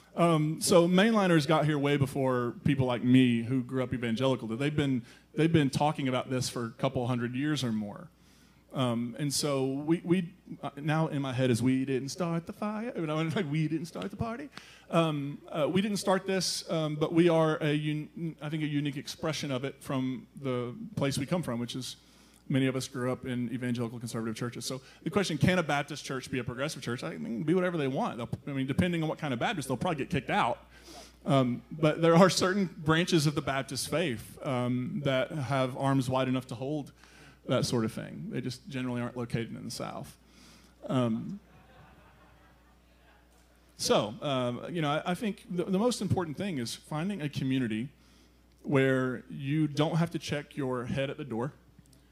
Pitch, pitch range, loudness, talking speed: 140 Hz, 125-160 Hz, -30 LUFS, 200 wpm